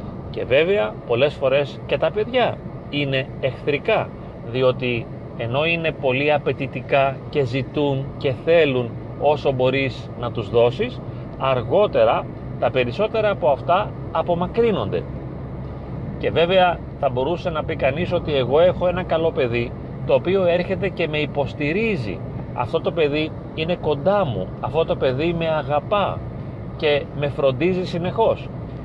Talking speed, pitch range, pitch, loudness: 130 wpm, 135-175 Hz, 145 Hz, -21 LUFS